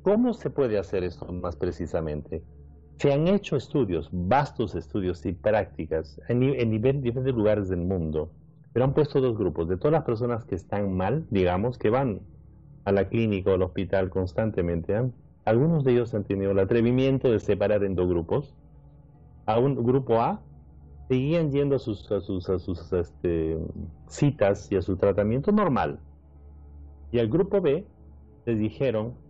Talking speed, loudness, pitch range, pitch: 170 wpm, -26 LUFS, 85-125 Hz, 100 Hz